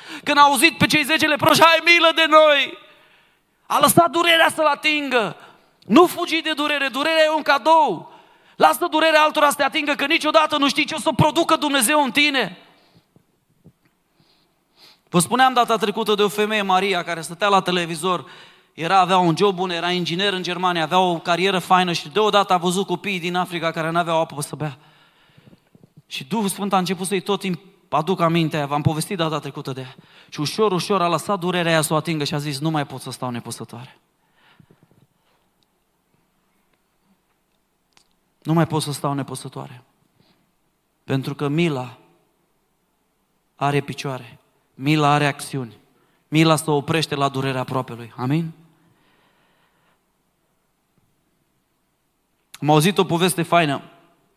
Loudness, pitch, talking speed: -19 LUFS, 180 Hz, 155 wpm